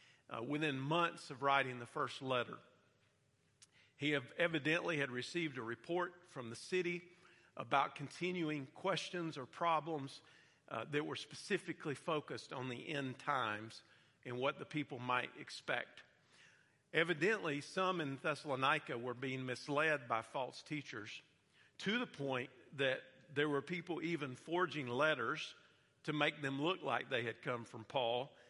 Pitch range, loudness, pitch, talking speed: 130-165 Hz, -40 LUFS, 145 Hz, 140 wpm